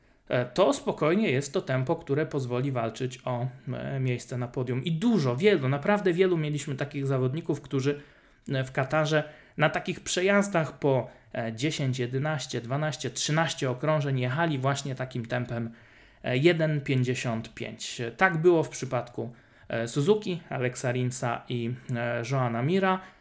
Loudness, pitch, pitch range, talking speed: -28 LUFS, 135 Hz, 125-155 Hz, 120 wpm